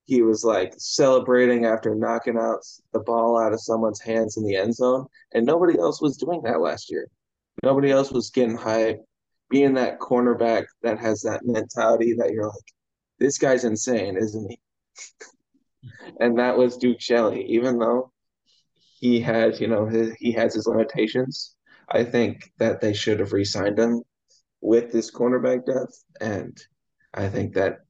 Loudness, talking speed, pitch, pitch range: -22 LUFS, 165 wpm, 115 Hz, 110-125 Hz